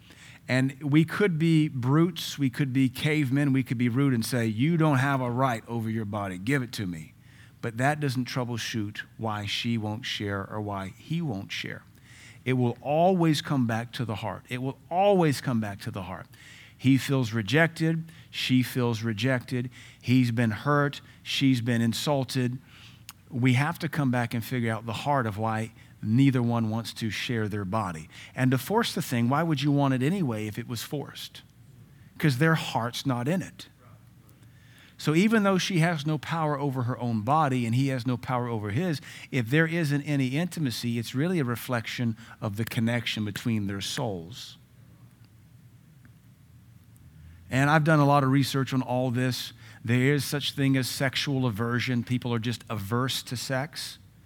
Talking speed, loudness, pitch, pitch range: 180 wpm, -27 LUFS, 125 Hz, 115-145 Hz